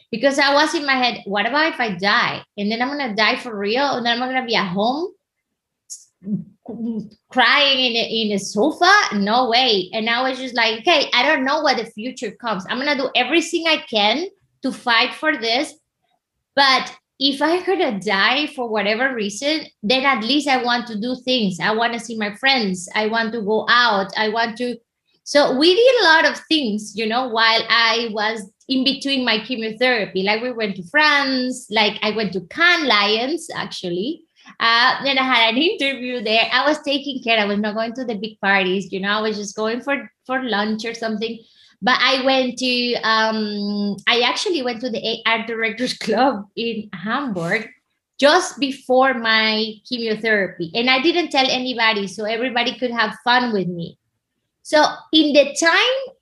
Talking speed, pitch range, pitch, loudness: 195 wpm, 215-270 Hz, 235 Hz, -18 LUFS